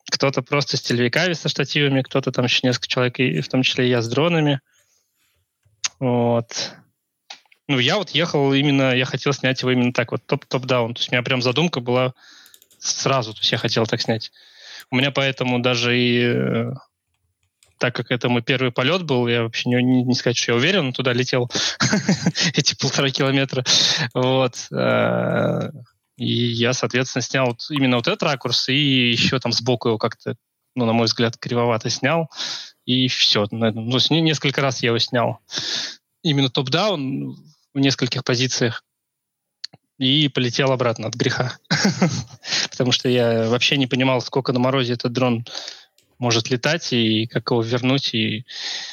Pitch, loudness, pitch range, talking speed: 130 Hz, -20 LUFS, 120-140 Hz, 165 wpm